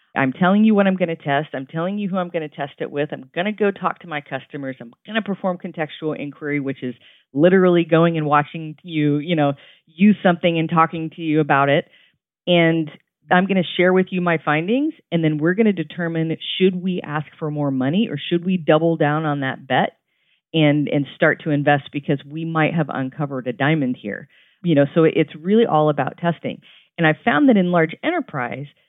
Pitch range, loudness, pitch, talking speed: 145-180 Hz, -19 LUFS, 160 Hz, 220 wpm